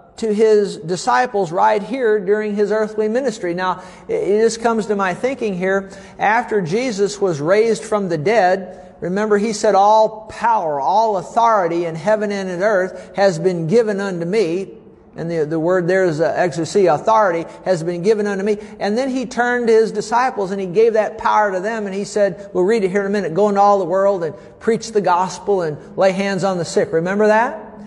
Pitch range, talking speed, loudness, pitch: 185-220 Hz, 205 wpm, -17 LUFS, 205 Hz